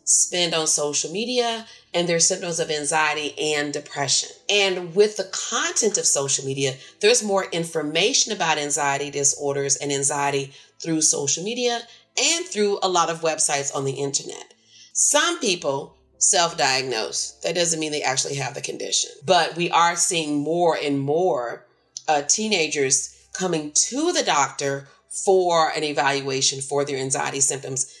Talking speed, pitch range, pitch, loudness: 150 wpm, 140-190 Hz, 155 Hz, -21 LUFS